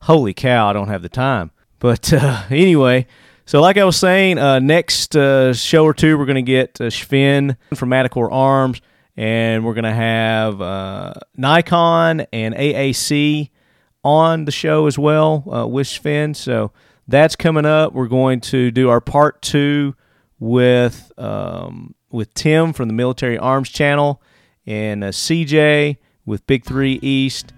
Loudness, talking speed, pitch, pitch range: -15 LUFS, 160 wpm, 135 Hz, 120-150 Hz